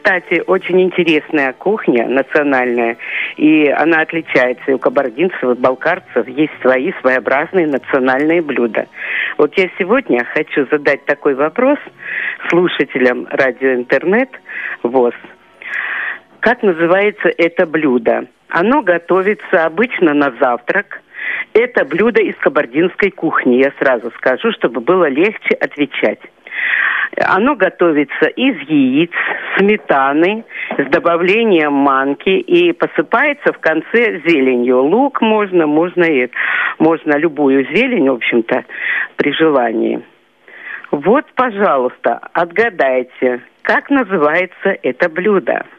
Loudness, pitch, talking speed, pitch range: -14 LUFS, 170 Hz, 105 wpm, 140-205 Hz